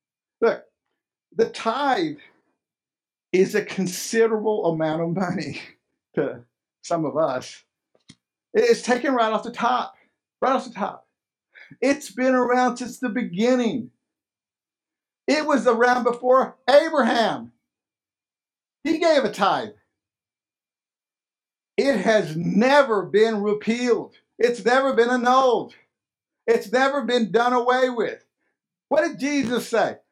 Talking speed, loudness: 115 wpm, -22 LUFS